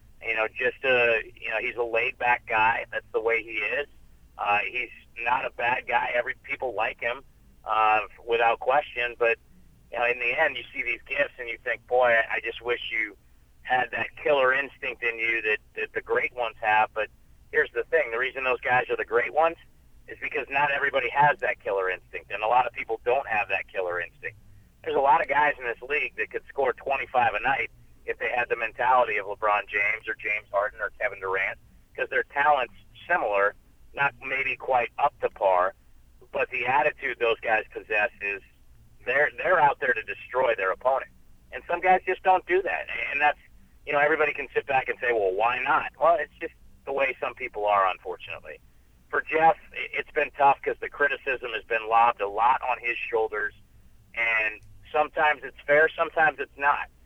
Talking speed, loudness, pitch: 205 wpm, -25 LUFS, 120 Hz